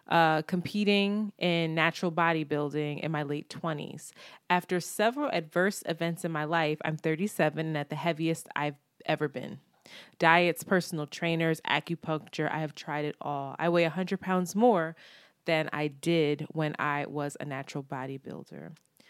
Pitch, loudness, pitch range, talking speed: 160 Hz, -30 LUFS, 150-175 Hz, 150 wpm